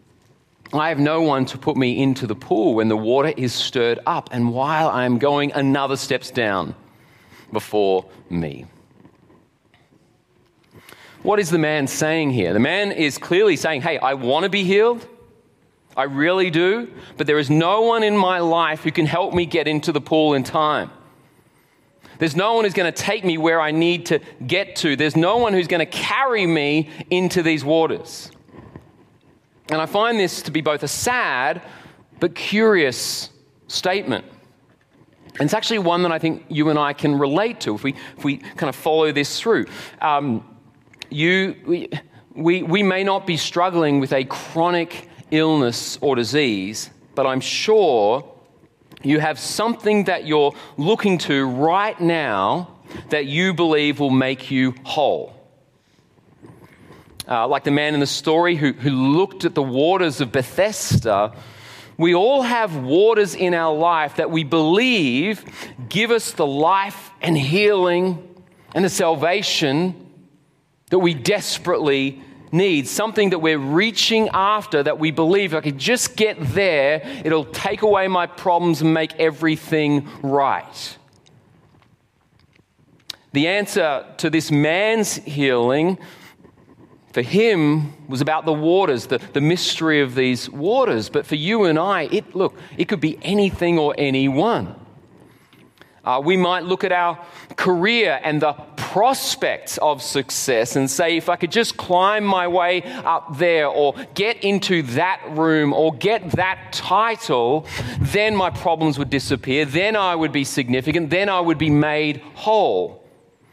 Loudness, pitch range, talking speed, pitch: -19 LUFS, 145-185 Hz, 160 wpm, 160 Hz